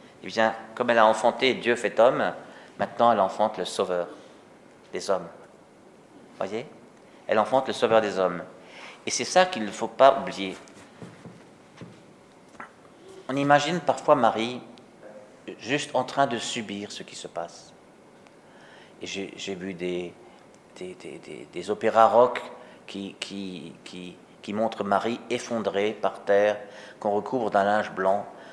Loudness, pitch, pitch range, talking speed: -25 LUFS, 105 Hz, 95-120 Hz, 145 wpm